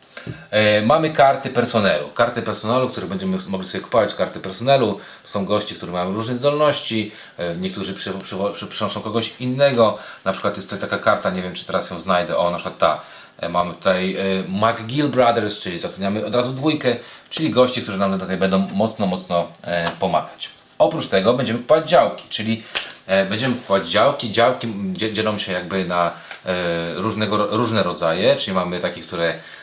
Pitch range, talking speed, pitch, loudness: 95-120 Hz, 160 wpm, 110 Hz, -20 LUFS